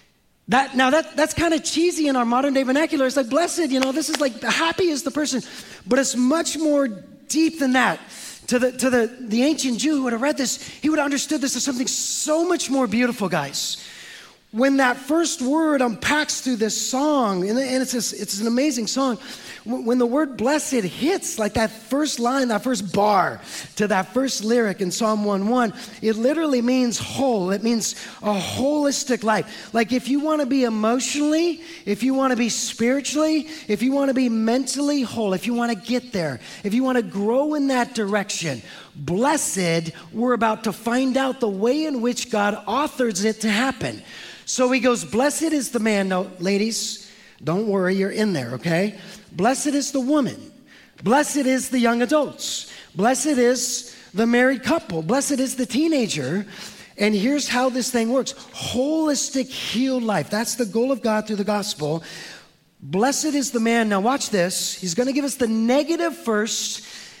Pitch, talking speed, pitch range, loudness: 245 Hz, 185 wpm, 215-275 Hz, -21 LUFS